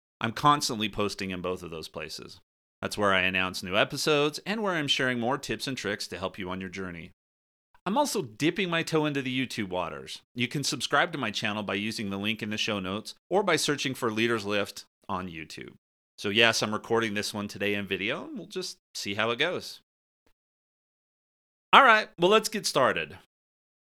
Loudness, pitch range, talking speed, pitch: -27 LUFS, 100-150 Hz, 200 wpm, 110 Hz